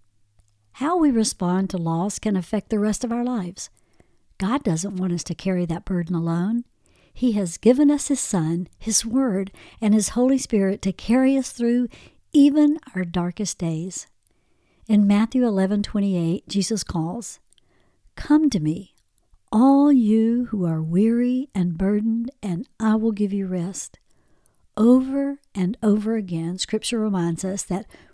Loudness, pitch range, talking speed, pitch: -22 LUFS, 180-240 Hz, 150 wpm, 210 Hz